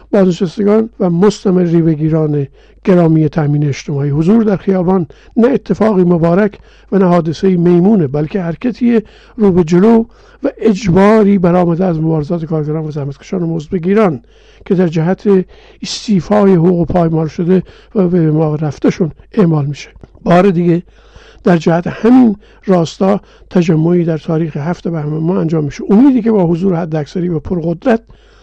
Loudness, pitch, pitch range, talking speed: -12 LUFS, 180 Hz, 165-200 Hz, 140 wpm